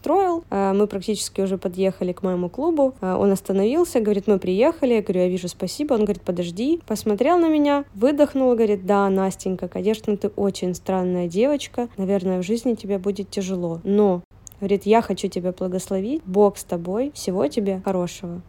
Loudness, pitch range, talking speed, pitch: -22 LUFS, 185-235 Hz, 165 wpm, 200 Hz